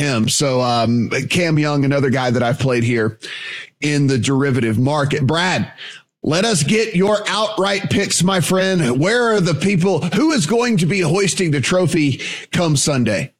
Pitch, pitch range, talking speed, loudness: 160 Hz, 135-190 Hz, 170 wpm, -16 LUFS